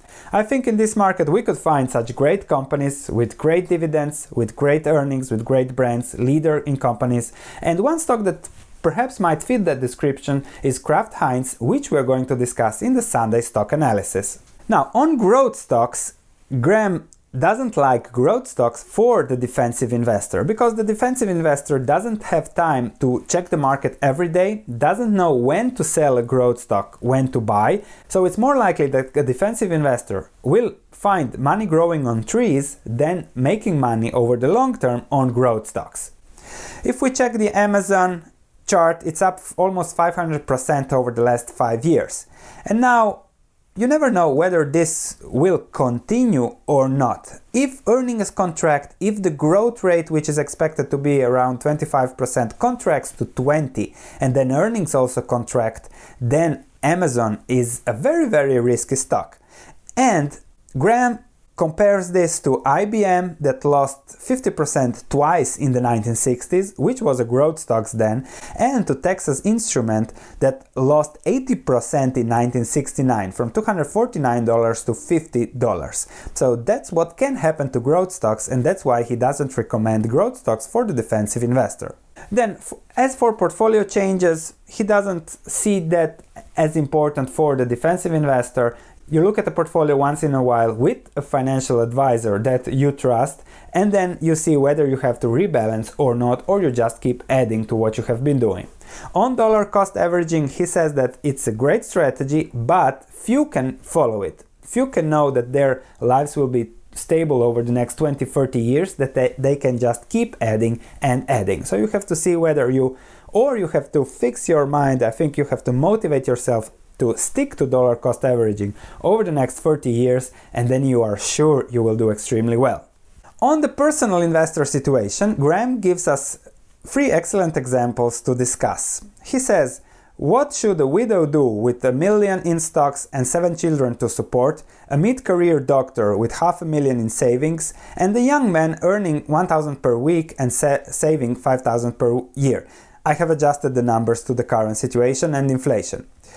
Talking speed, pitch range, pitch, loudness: 170 wpm, 125-175 Hz, 145 Hz, -19 LUFS